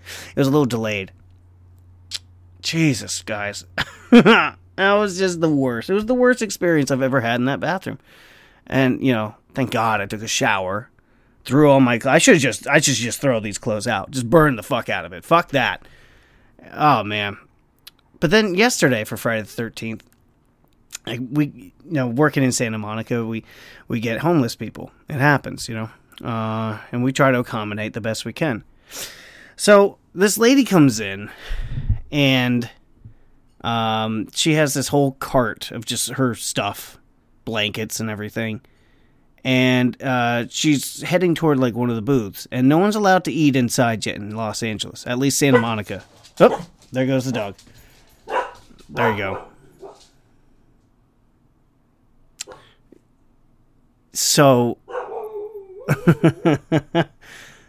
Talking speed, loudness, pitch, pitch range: 150 wpm, -19 LUFS, 125 Hz, 110-145 Hz